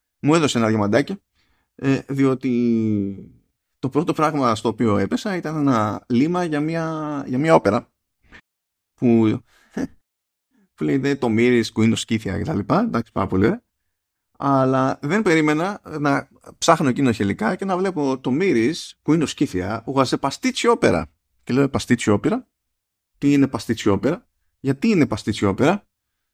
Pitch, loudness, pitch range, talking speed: 125 Hz, -20 LUFS, 105-150 Hz, 145 wpm